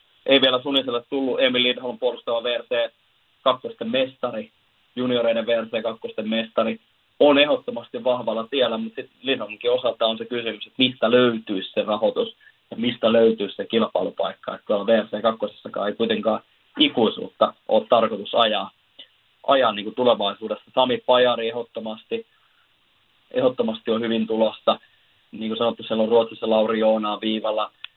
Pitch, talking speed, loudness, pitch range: 115 Hz, 135 wpm, -22 LUFS, 110-125 Hz